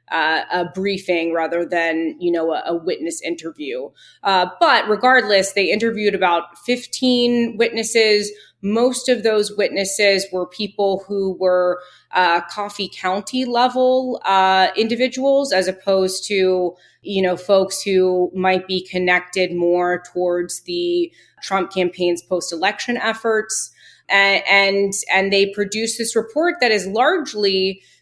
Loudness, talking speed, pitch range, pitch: -18 LUFS, 130 wpm, 180-225 Hz, 195 Hz